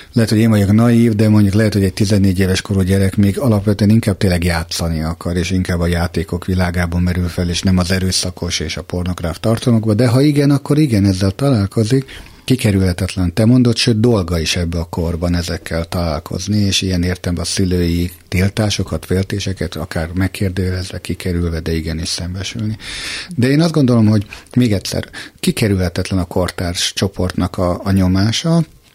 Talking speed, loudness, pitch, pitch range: 165 wpm, -16 LUFS, 95 Hz, 90-110 Hz